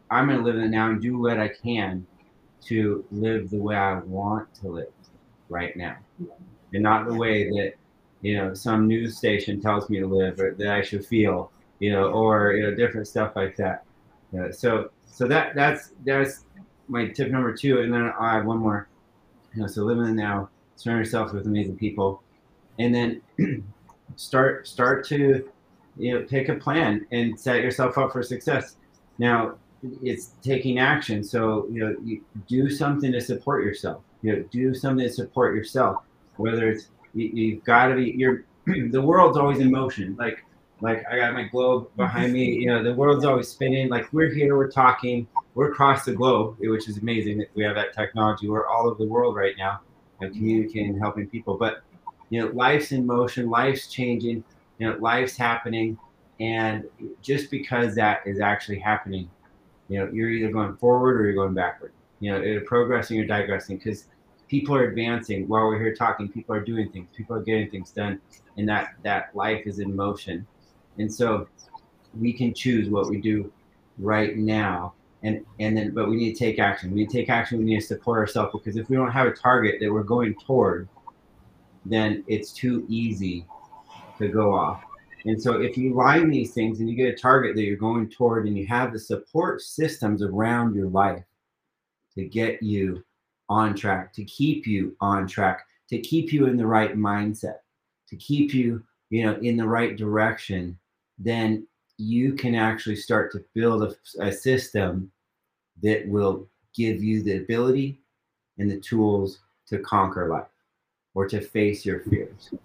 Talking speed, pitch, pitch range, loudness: 190 wpm, 110 Hz, 105-120 Hz, -24 LUFS